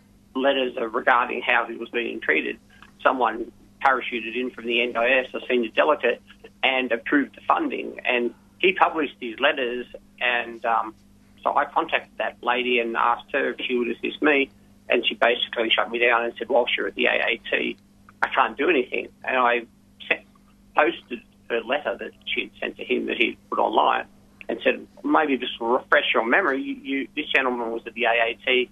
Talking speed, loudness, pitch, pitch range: 185 wpm, -23 LUFS, 120 Hz, 115-125 Hz